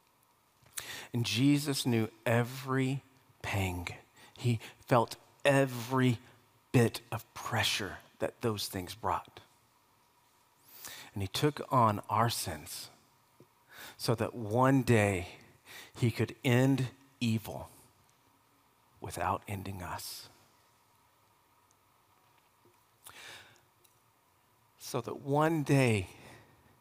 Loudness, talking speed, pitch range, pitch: -32 LUFS, 80 wpm, 110-130 Hz, 120 Hz